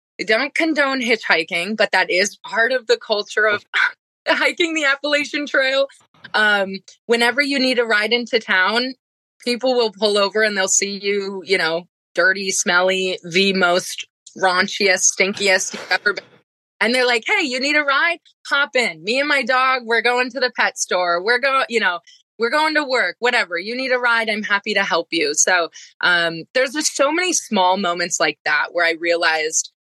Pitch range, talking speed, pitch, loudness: 185-260 Hz, 190 wpm, 220 Hz, -18 LUFS